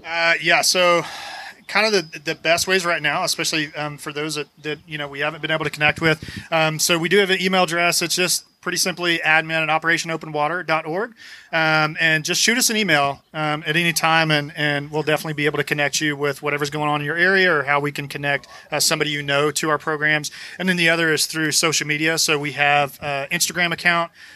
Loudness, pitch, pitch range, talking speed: -19 LUFS, 155 Hz, 150-170 Hz, 230 wpm